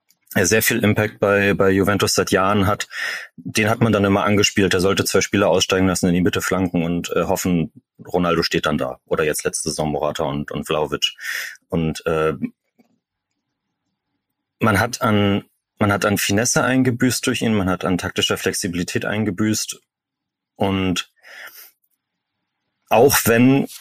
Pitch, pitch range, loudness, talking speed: 100 Hz, 90-110 Hz, -19 LUFS, 155 wpm